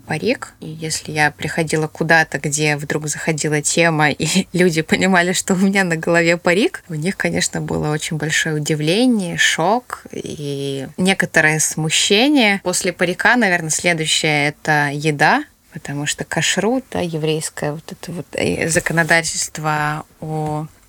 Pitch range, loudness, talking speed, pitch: 155-180 Hz, -17 LUFS, 130 wpm, 160 Hz